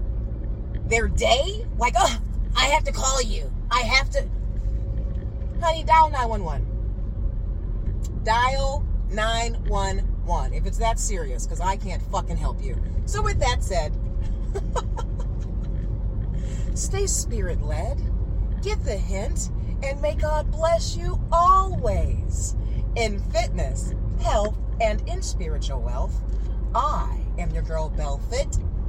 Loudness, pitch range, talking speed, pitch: -25 LUFS, 90-105 Hz, 115 wpm, 95 Hz